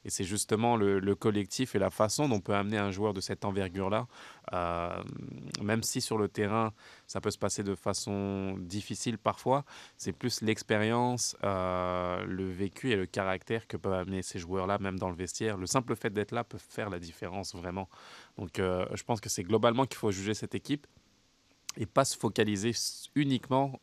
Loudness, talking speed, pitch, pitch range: -32 LUFS, 195 wpm, 105 Hz, 95-115 Hz